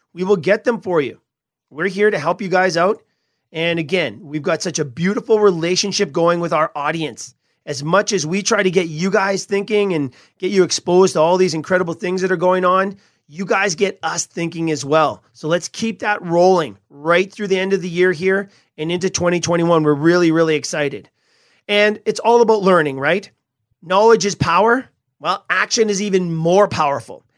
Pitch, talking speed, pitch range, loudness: 180 Hz, 195 wpm, 160-200 Hz, -17 LUFS